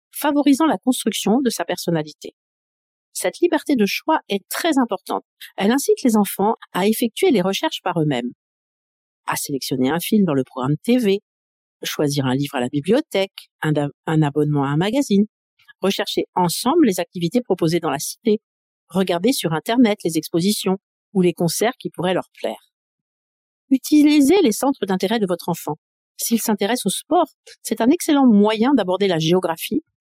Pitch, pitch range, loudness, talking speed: 200 Hz, 170-245 Hz, -20 LUFS, 165 wpm